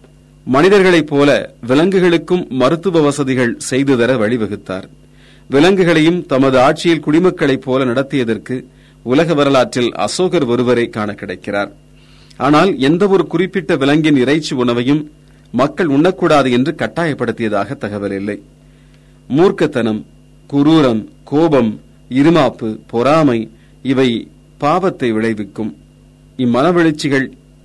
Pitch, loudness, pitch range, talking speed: 130 Hz, -14 LUFS, 110-160 Hz, 90 wpm